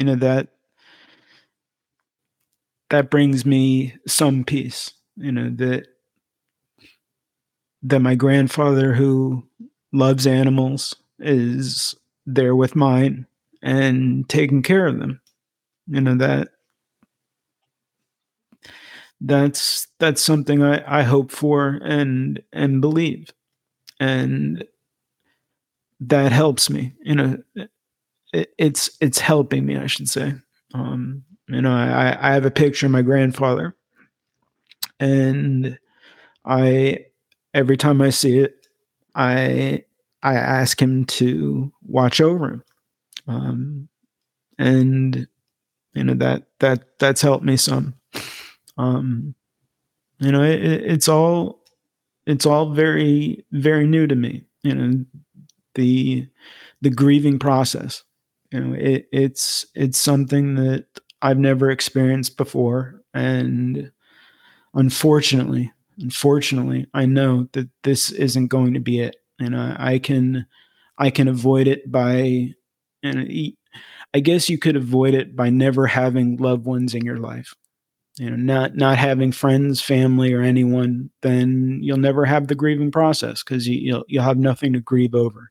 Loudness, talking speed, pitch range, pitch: -19 LUFS, 125 wpm, 125-140 Hz, 135 Hz